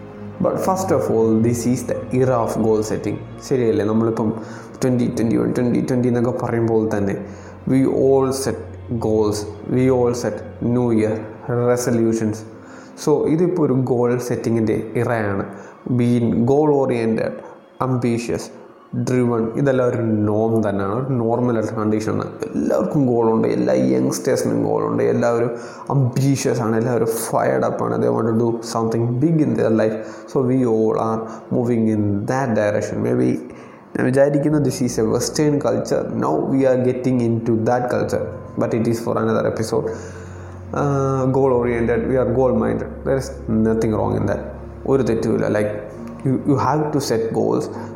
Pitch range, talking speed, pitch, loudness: 110-125 Hz, 150 wpm, 115 Hz, -19 LUFS